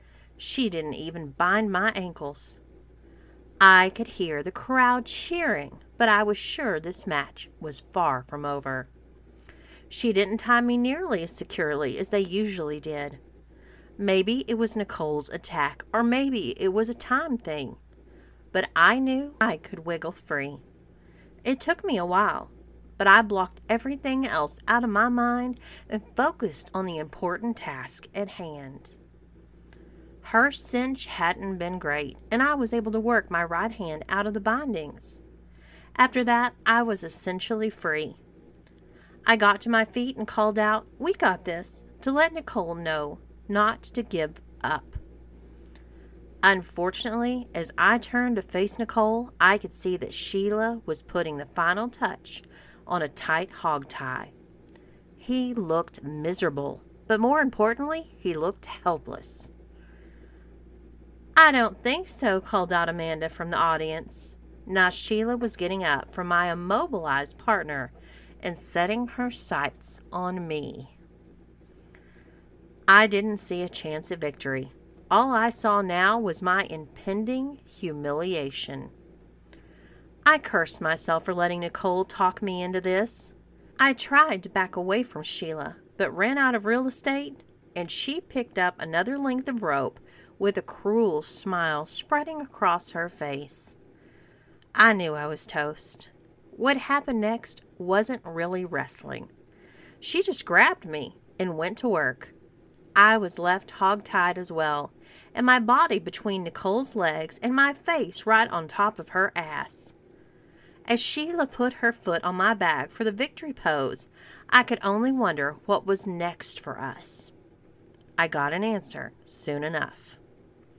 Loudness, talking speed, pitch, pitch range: -25 LUFS, 145 wpm, 190 Hz, 165-235 Hz